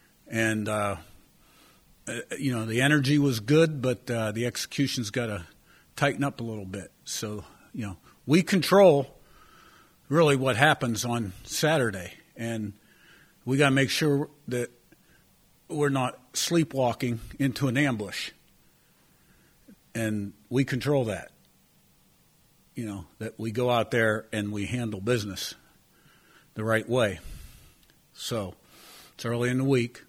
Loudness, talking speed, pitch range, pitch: -27 LUFS, 130 wpm, 110-140 Hz, 120 Hz